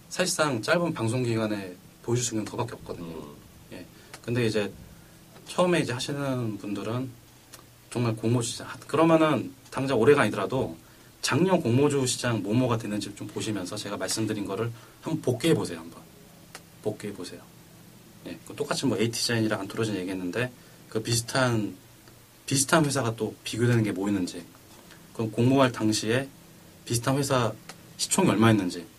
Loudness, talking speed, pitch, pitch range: -27 LUFS, 335 characters per minute, 115 Hz, 105-135 Hz